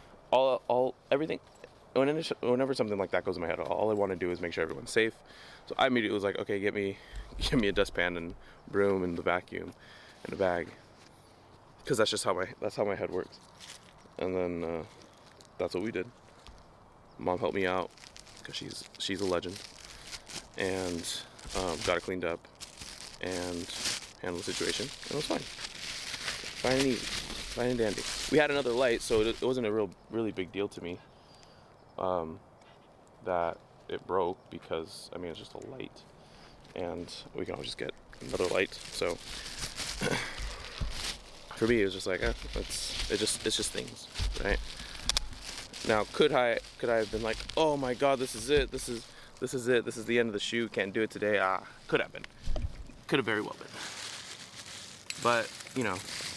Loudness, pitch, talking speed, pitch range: -32 LUFS, 105 Hz, 185 wpm, 90-120 Hz